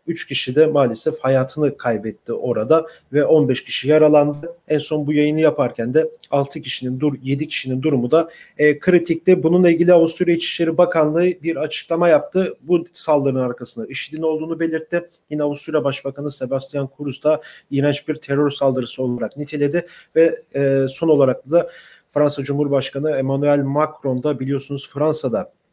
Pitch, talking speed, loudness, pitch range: 150 Hz, 150 wpm, -19 LUFS, 140-165 Hz